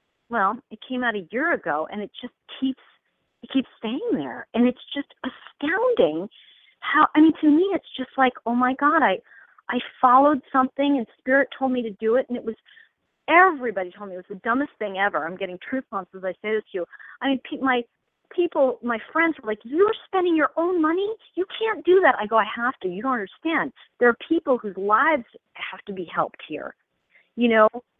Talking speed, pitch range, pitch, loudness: 215 wpm, 220-300 Hz, 255 Hz, -23 LUFS